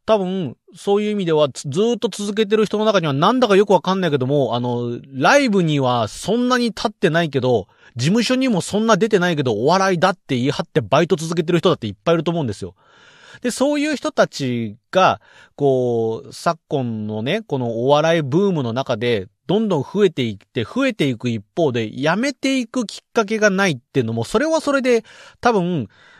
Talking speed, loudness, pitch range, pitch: 395 characters per minute, -19 LUFS, 130-220 Hz, 175 Hz